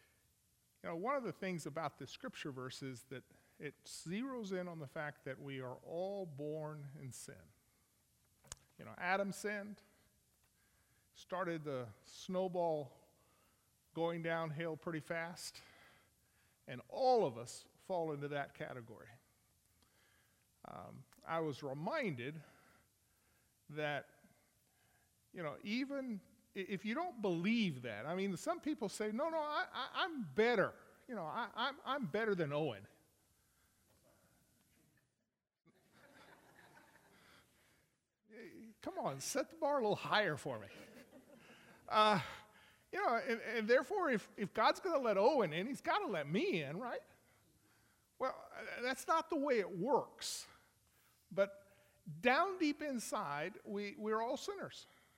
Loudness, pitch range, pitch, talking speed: -40 LUFS, 150-240 Hz, 190 Hz, 135 wpm